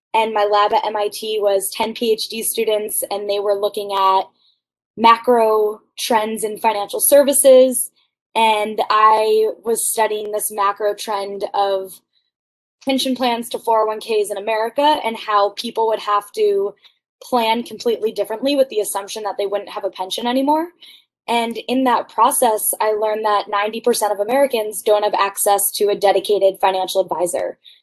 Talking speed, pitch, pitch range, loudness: 150 wpm, 215 Hz, 205-235 Hz, -18 LUFS